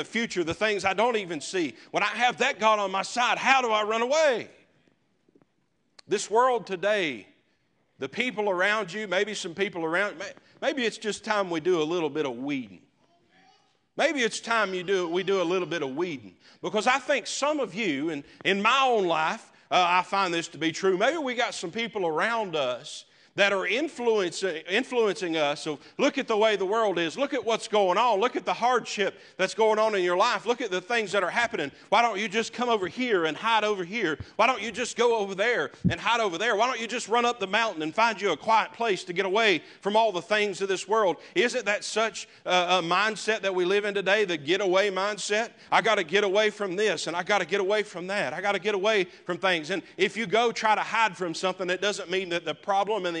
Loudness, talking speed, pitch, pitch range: -26 LUFS, 240 wpm, 210 Hz, 185-235 Hz